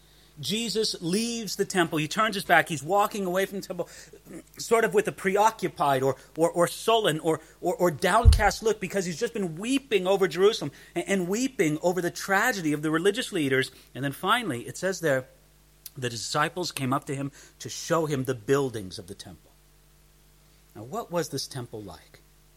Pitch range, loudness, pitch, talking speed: 140-195 Hz, -26 LUFS, 165 Hz, 185 wpm